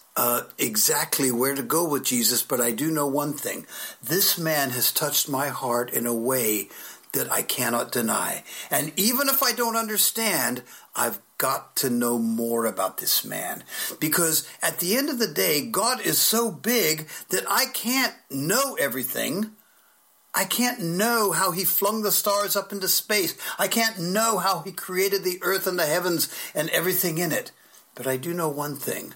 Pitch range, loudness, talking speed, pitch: 145-215 Hz, -23 LUFS, 180 wpm, 180 Hz